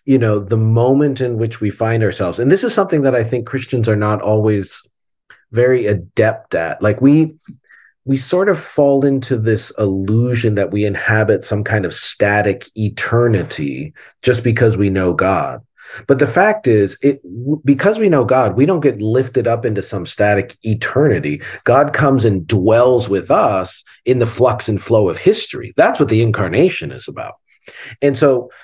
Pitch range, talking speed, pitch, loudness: 105-135 Hz, 175 wpm, 120 Hz, -15 LUFS